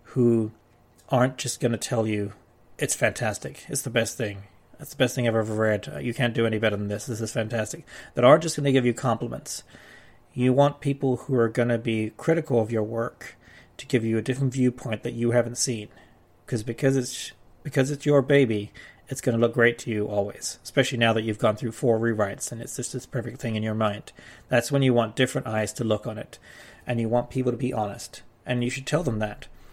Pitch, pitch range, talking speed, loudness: 120 Hz, 110-130 Hz, 230 wpm, -25 LUFS